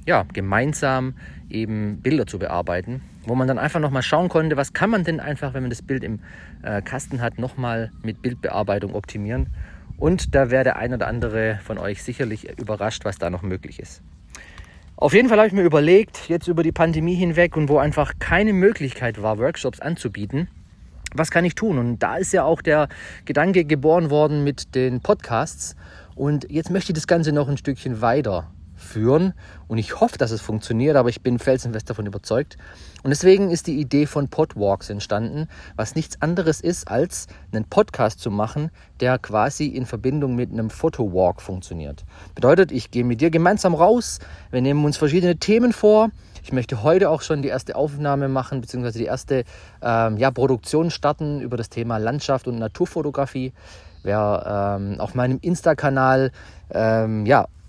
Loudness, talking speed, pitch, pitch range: -21 LUFS, 180 wpm, 130 Hz, 110-155 Hz